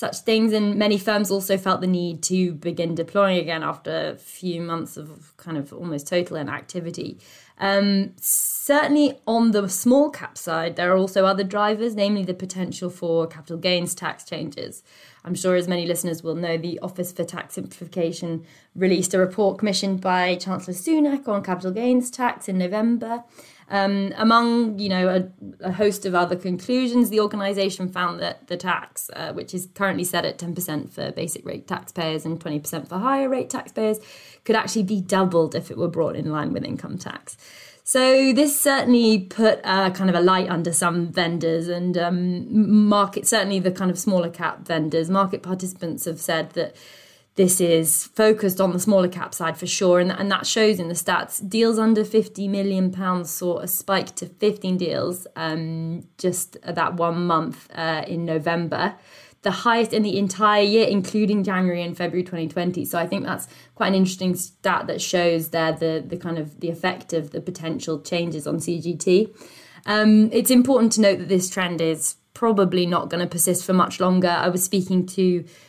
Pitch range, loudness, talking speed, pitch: 170-205 Hz, -22 LUFS, 185 wpm, 185 Hz